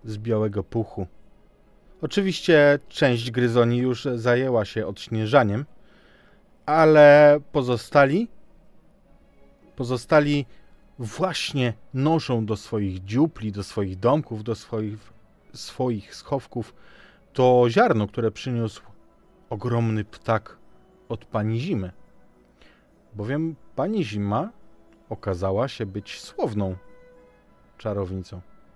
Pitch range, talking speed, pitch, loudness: 105-135 Hz, 90 wpm, 115 Hz, -23 LUFS